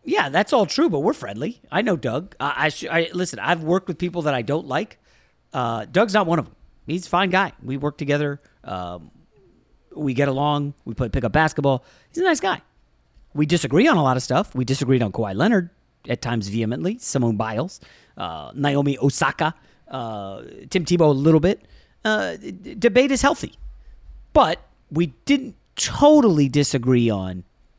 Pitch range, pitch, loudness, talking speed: 130-180 Hz, 145 Hz, -21 LUFS, 185 wpm